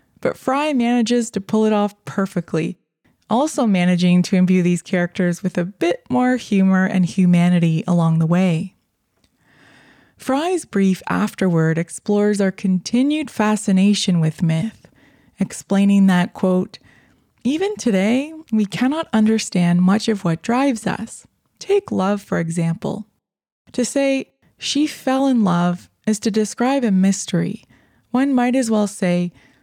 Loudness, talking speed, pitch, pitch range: -19 LUFS, 135 wpm, 200 Hz, 180-240 Hz